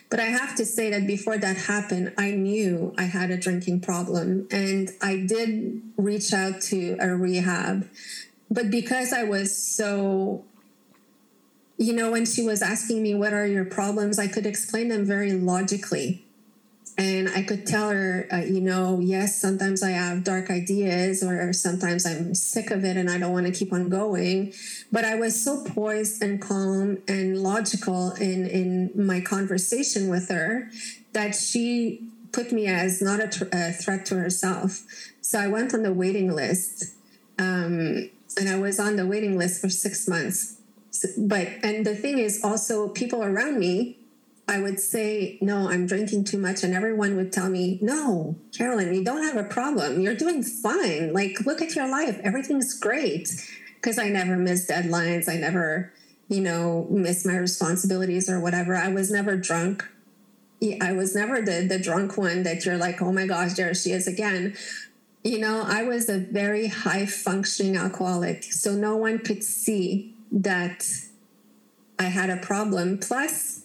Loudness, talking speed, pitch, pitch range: -25 LUFS, 175 wpm, 195 Hz, 185-215 Hz